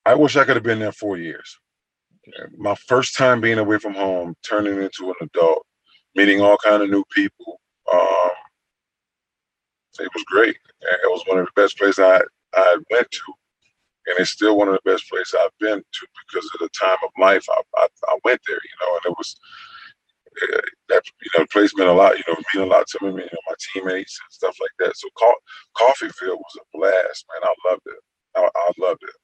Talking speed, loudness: 220 wpm, -19 LUFS